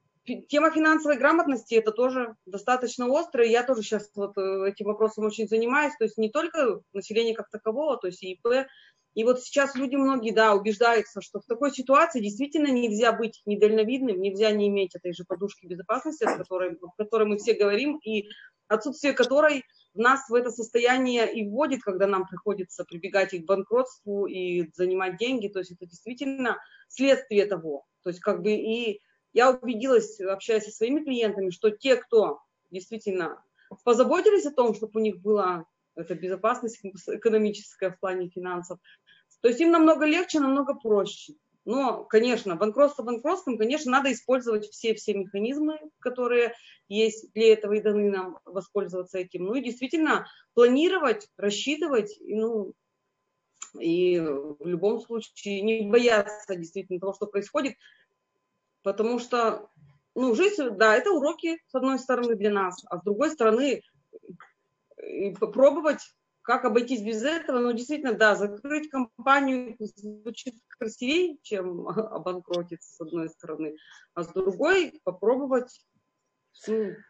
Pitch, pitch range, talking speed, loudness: 220 Hz, 200-260 Hz, 145 wpm, -26 LUFS